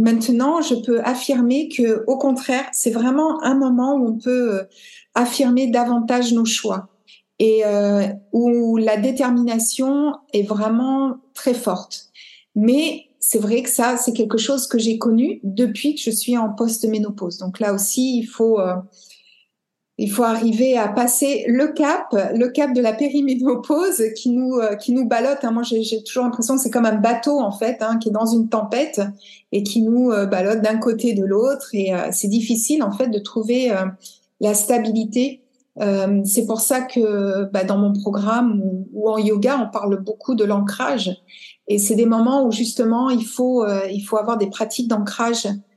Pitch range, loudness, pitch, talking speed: 210-255 Hz, -19 LUFS, 230 Hz, 180 wpm